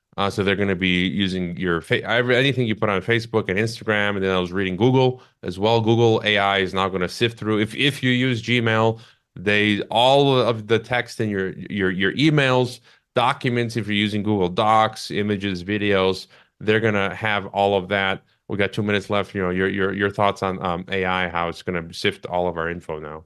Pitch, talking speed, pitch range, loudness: 105 Hz, 220 wpm, 95-115 Hz, -21 LUFS